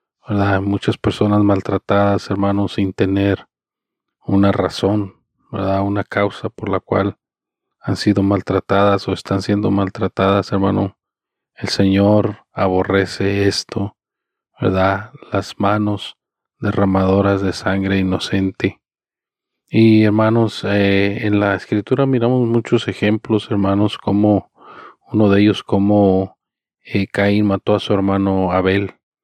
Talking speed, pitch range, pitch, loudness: 115 wpm, 95-105 Hz, 100 Hz, -17 LUFS